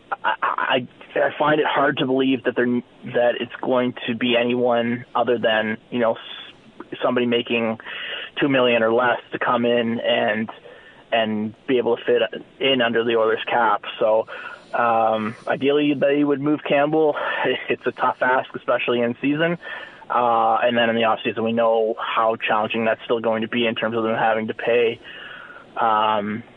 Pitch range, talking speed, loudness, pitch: 115-125 Hz, 175 wpm, -21 LUFS, 120 Hz